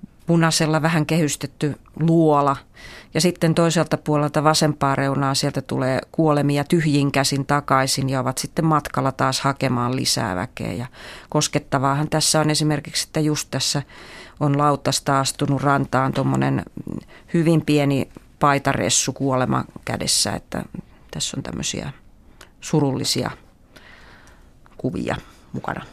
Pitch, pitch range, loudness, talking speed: 145 Hz, 135-155 Hz, -20 LUFS, 115 wpm